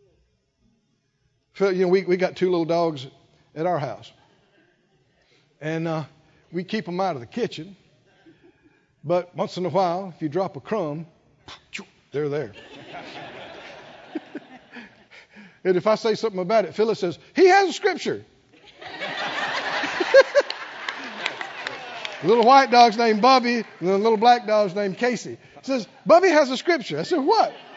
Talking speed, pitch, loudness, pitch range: 145 wpm, 190 Hz, -21 LUFS, 160-235 Hz